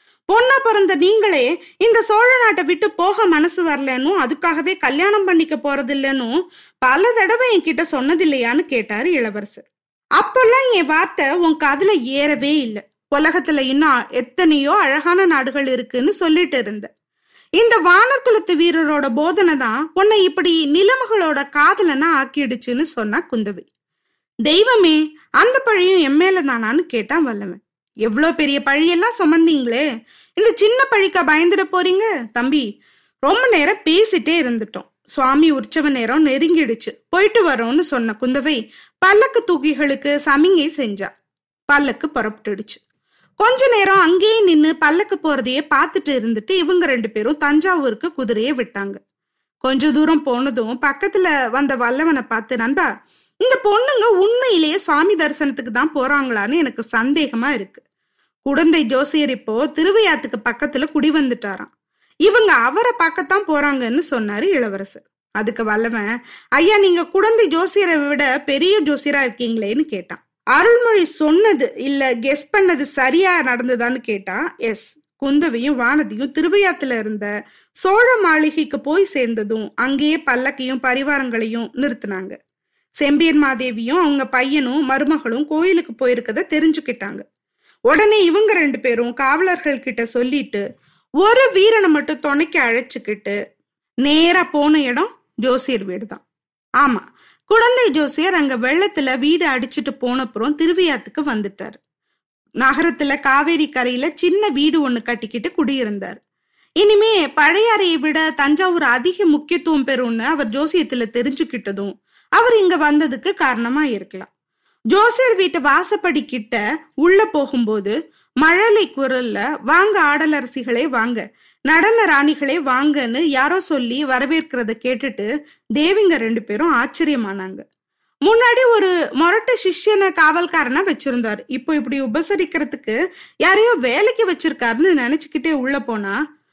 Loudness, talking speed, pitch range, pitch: -16 LUFS, 110 wpm, 255-360 Hz, 300 Hz